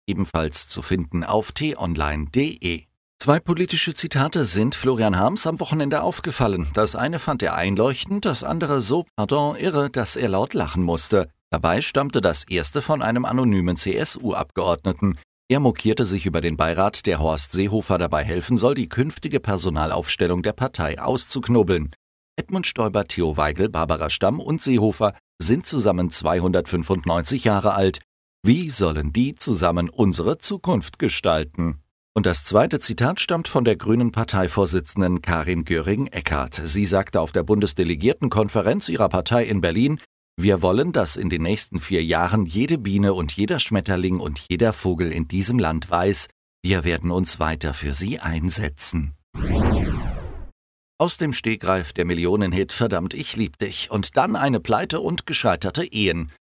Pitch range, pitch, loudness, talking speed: 85-120 Hz, 95 Hz, -21 LUFS, 150 wpm